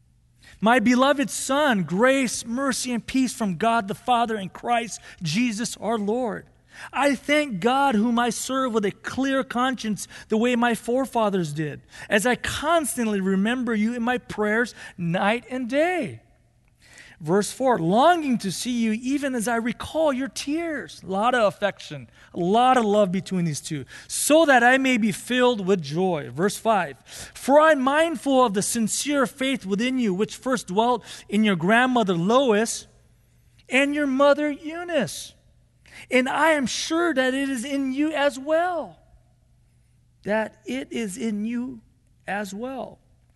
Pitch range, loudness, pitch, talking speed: 205-265 Hz, -23 LUFS, 240 Hz, 160 wpm